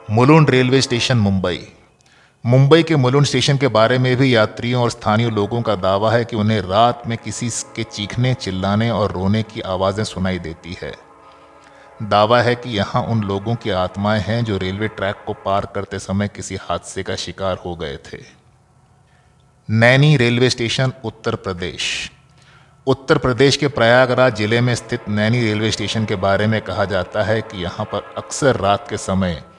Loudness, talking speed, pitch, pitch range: -17 LUFS, 170 wpm, 110 Hz, 100-125 Hz